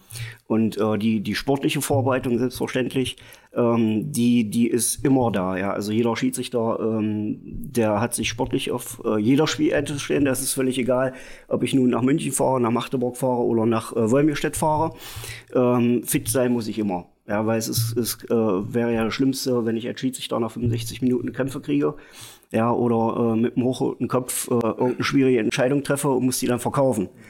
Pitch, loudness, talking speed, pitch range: 120 Hz, -22 LUFS, 190 wpm, 115-130 Hz